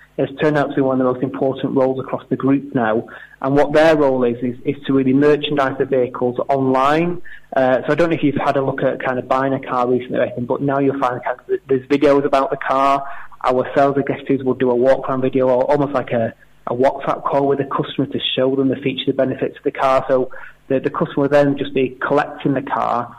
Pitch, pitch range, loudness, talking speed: 135 Hz, 130-140 Hz, -18 LUFS, 255 wpm